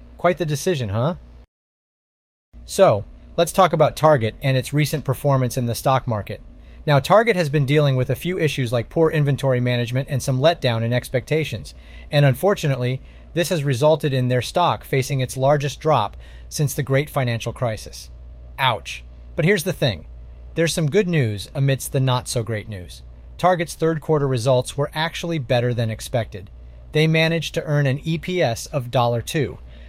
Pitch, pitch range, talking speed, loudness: 135 Hz, 115-155 Hz, 170 wpm, -20 LUFS